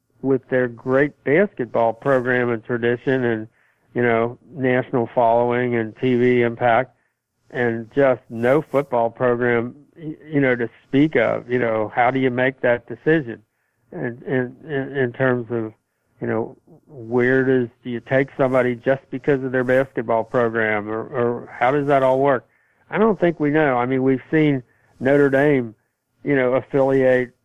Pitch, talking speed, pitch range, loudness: 125 Hz, 165 wpm, 120-135 Hz, -20 LUFS